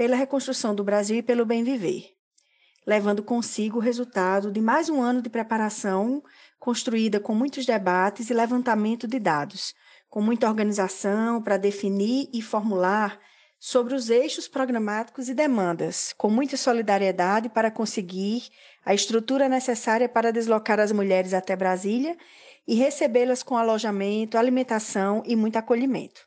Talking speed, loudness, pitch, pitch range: 140 wpm, -24 LUFS, 225 Hz, 210-250 Hz